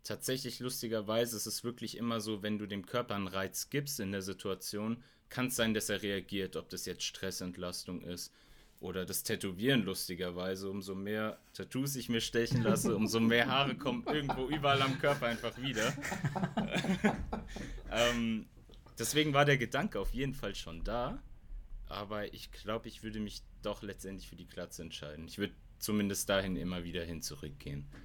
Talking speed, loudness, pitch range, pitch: 170 wpm, -36 LUFS, 95-120 Hz, 105 Hz